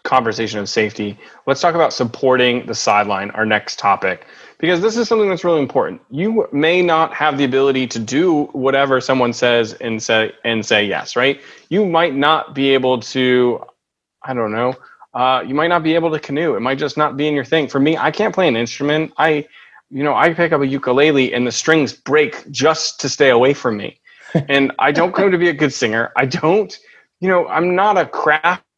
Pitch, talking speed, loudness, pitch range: 140 Hz, 215 wpm, -16 LUFS, 125-160 Hz